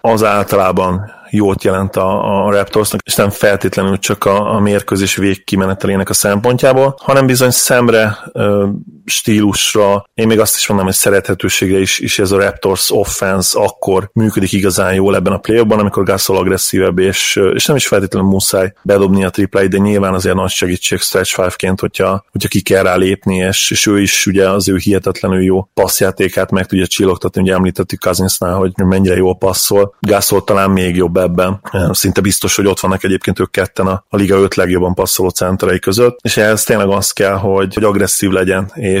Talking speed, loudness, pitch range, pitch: 185 wpm, -12 LUFS, 95-100 Hz, 95 Hz